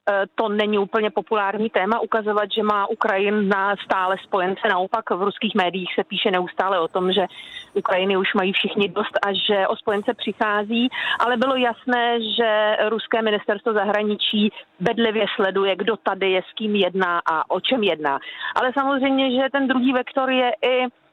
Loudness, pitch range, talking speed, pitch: -21 LUFS, 195-235 Hz, 165 wpm, 215 Hz